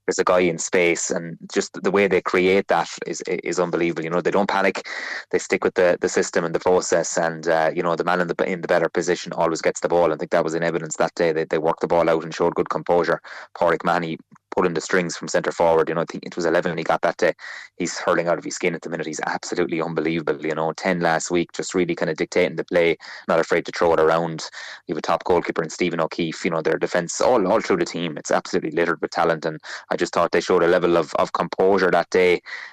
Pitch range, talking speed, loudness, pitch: 80-90 Hz, 275 wpm, -21 LUFS, 85 Hz